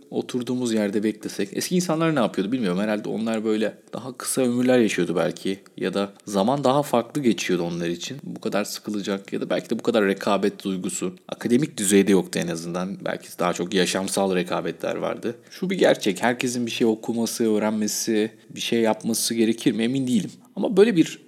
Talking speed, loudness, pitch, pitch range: 180 wpm, -23 LUFS, 110 Hz, 100-120 Hz